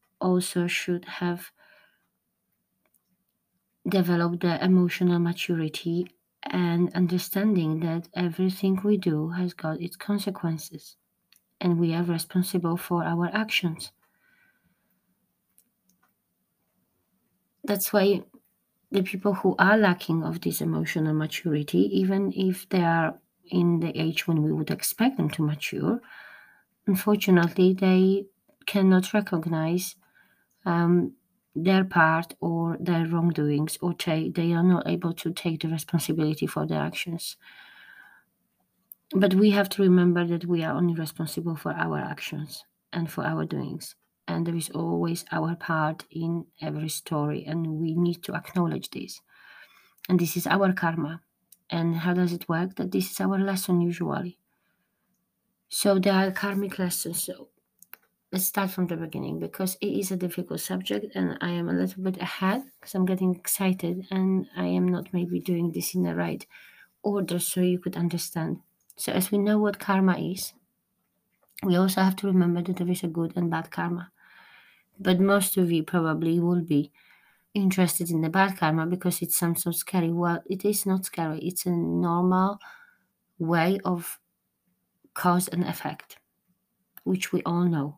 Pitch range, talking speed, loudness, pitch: 165-190 Hz, 150 wpm, -26 LUFS, 175 Hz